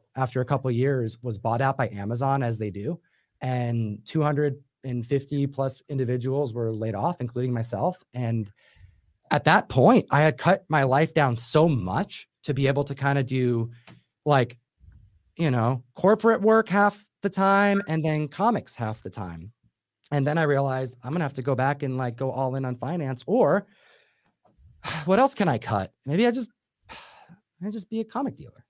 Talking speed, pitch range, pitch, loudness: 185 wpm, 120-165 Hz, 135 Hz, -25 LUFS